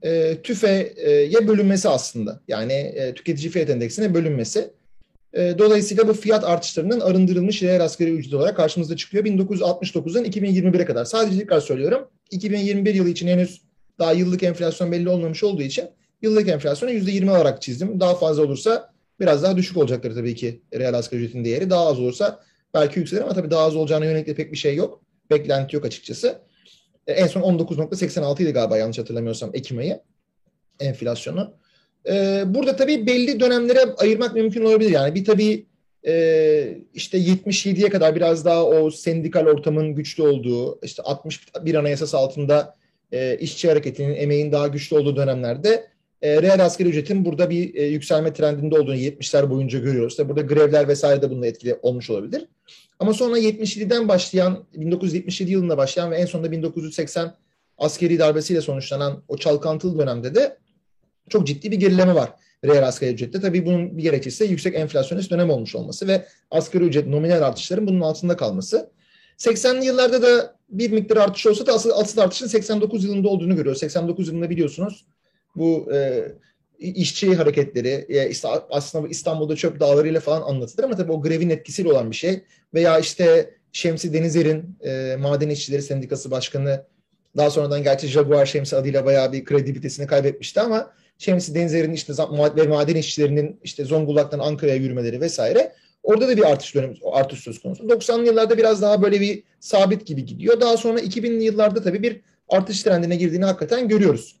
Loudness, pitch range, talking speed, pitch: -20 LUFS, 145-200 Hz, 160 wpm, 170 Hz